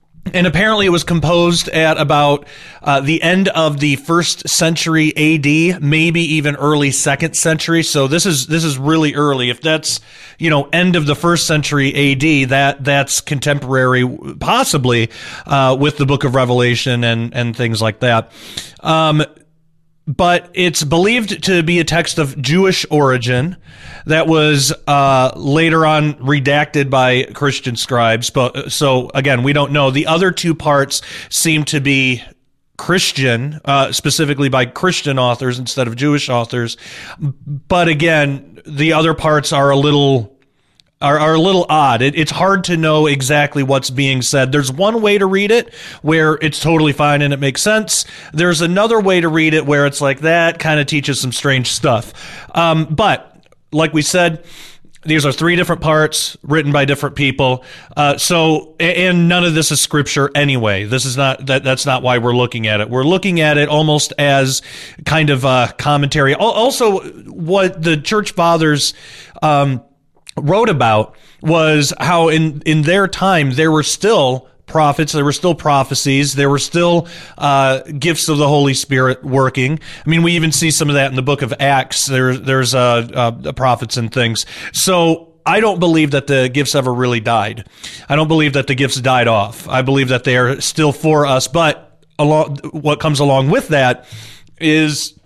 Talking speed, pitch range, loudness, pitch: 175 wpm, 135-160 Hz, -13 LUFS, 145 Hz